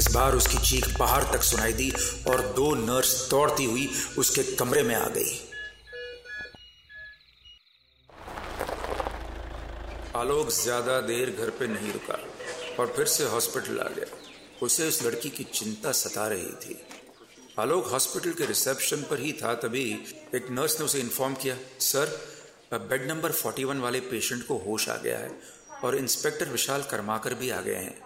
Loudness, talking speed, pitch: -27 LUFS, 155 wpm, 160 Hz